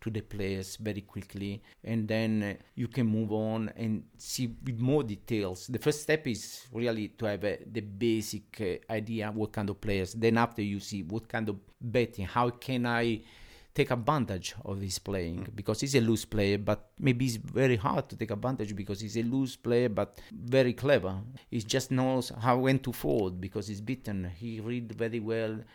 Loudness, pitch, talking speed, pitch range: -32 LUFS, 110 Hz, 200 wpm, 105-120 Hz